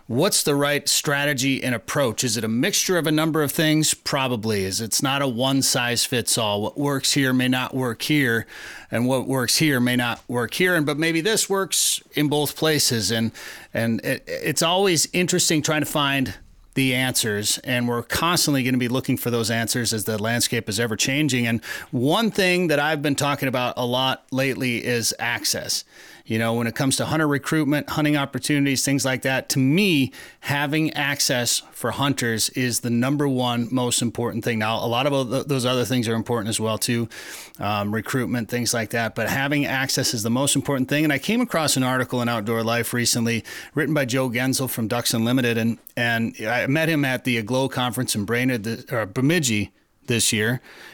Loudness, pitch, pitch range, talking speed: -21 LUFS, 130 Hz, 120-145 Hz, 200 wpm